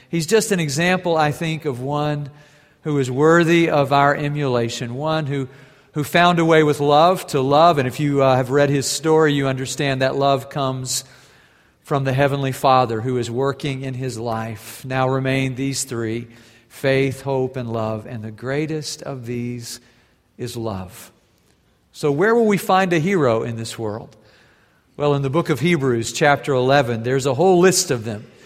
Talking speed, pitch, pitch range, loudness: 180 wpm, 135 Hz, 125-150 Hz, -19 LUFS